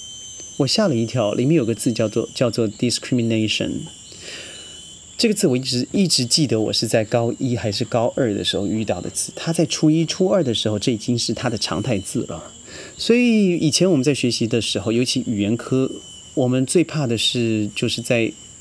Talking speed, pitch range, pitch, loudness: 320 characters per minute, 110-145 Hz, 120 Hz, -20 LUFS